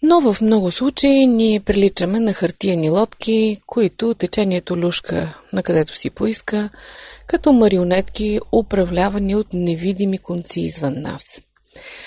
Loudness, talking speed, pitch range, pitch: -18 LUFS, 120 wpm, 180-225 Hz, 205 Hz